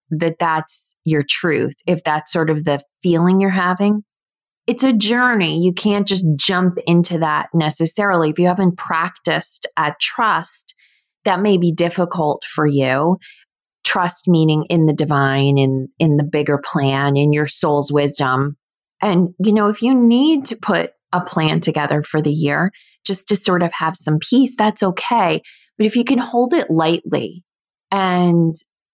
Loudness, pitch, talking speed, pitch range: -17 LUFS, 170 Hz, 165 wpm, 150-195 Hz